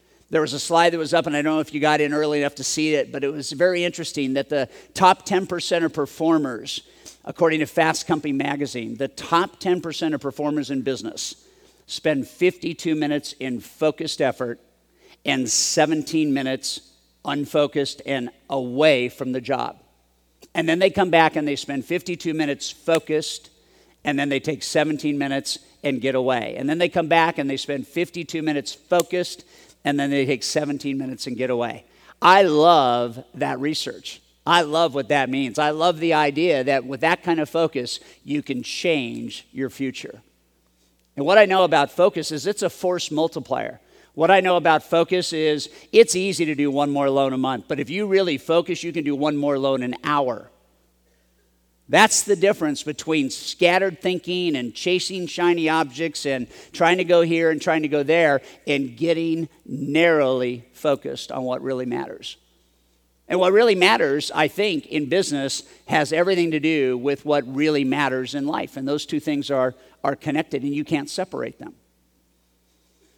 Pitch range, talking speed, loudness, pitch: 135-165 Hz, 180 wpm, -21 LUFS, 150 Hz